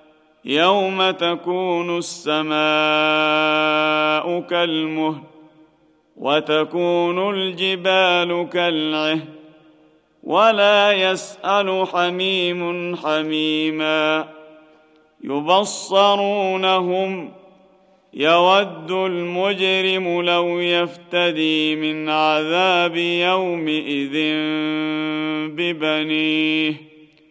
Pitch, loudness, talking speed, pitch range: 170 Hz, -19 LUFS, 45 wpm, 155-185 Hz